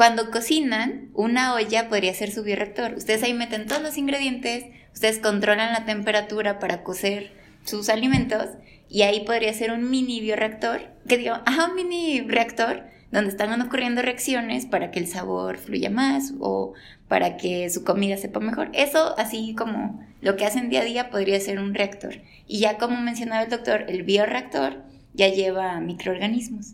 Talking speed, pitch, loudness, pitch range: 170 wpm, 220 Hz, -24 LUFS, 200-240 Hz